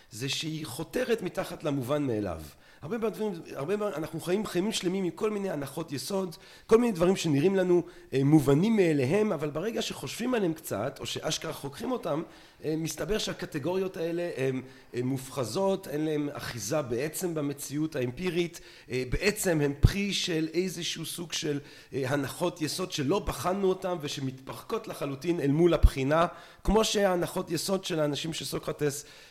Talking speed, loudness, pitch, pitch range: 145 wpm, -30 LUFS, 165 Hz, 145-185 Hz